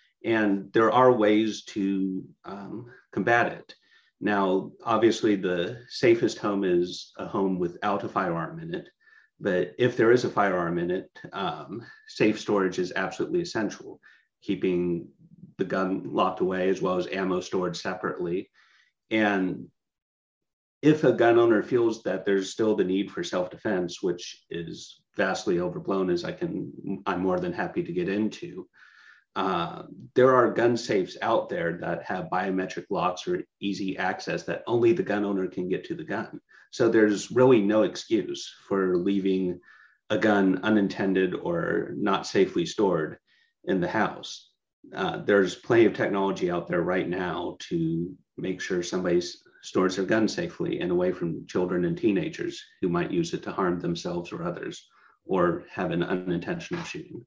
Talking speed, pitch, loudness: 160 wpm, 110 Hz, -26 LUFS